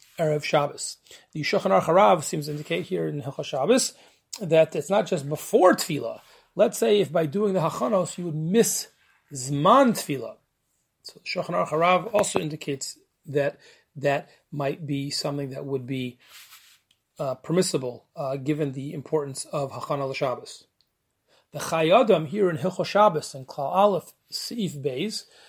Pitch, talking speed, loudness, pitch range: 155 Hz, 145 wpm, -24 LUFS, 140-190 Hz